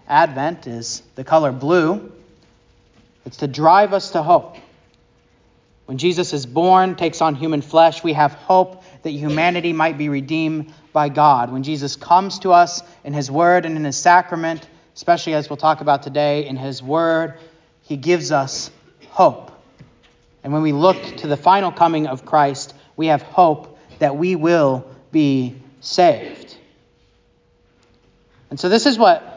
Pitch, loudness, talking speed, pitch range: 155 Hz, -17 LUFS, 155 wpm, 140-170 Hz